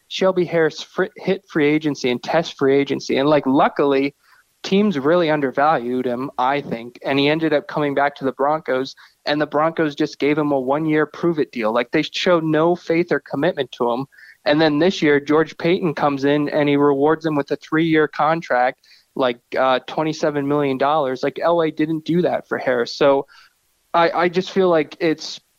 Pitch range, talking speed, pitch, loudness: 140-165 Hz, 195 wpm, 150 Hz, -19 LUFS